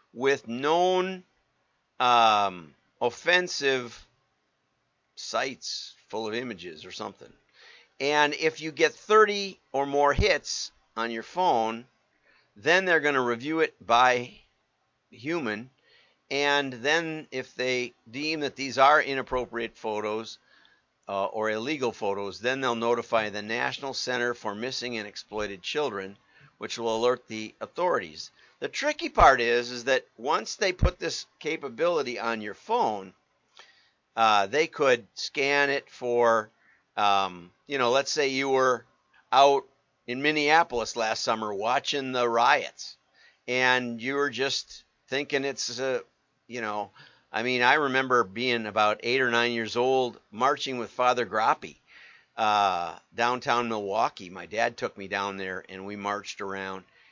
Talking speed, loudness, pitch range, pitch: 140 wpm, -26 LUFS, 110-140 Hz, 125 Hz